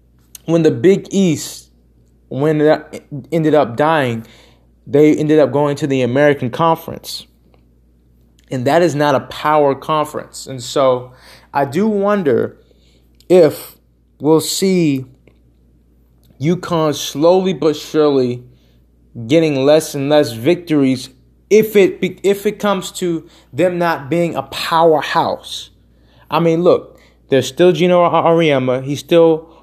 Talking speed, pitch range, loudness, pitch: 125 wpm, 115-165 Hz, -15 LUFS, 145 Hz